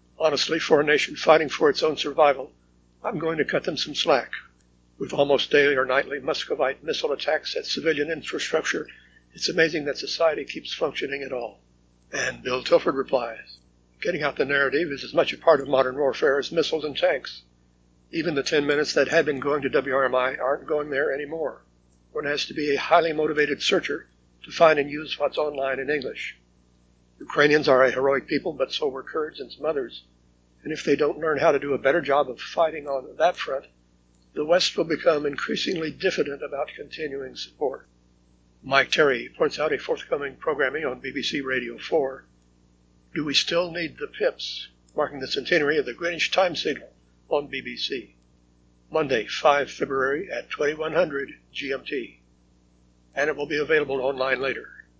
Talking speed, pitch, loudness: 175 wpm, 135 Hz, -24 LUFS